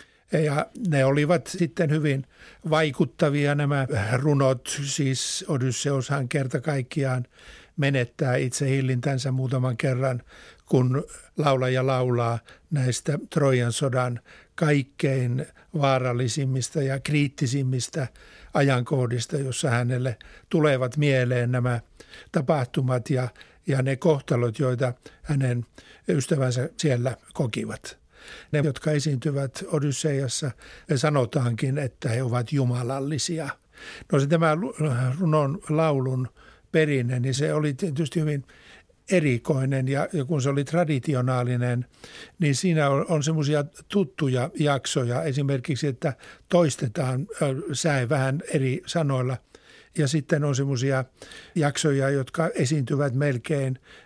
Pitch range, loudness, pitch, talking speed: 130-155 Hz, -25 LUFS, 140 Hz, 105 wpm